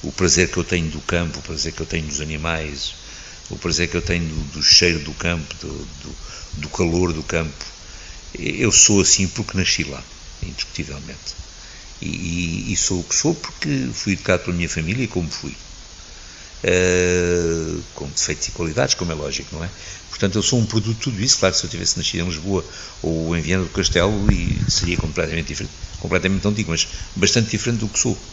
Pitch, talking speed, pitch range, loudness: 85 Hz, 200 wpm, 80-95 Hz, -19 LUFS